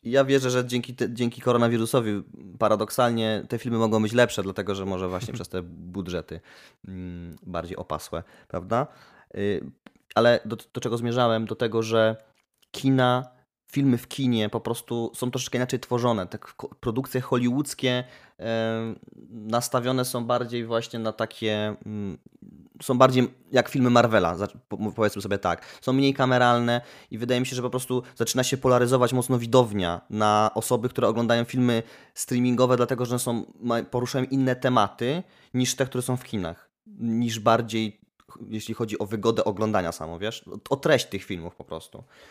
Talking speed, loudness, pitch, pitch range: 155 wpm, -25 LUFS, 120 Hz, 110-125 Hz